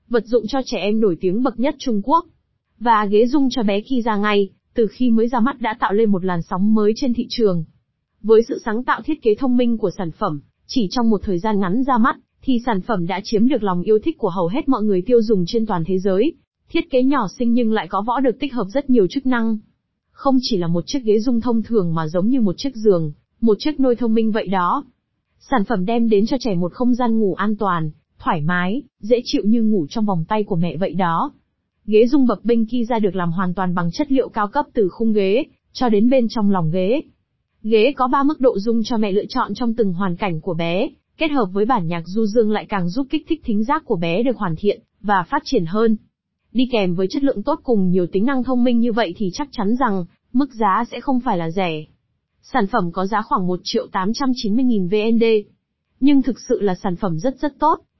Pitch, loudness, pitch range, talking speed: 220 Hz, -19 LUFS, 195-250 Hz, 250 wpm